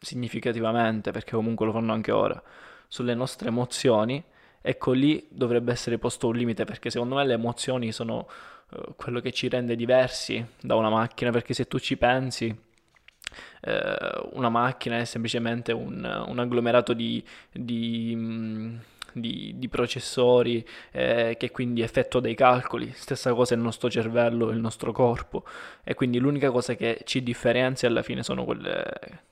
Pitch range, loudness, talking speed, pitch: 115-125 Hz, -26 LUFS, 150 wpm, 120 Hz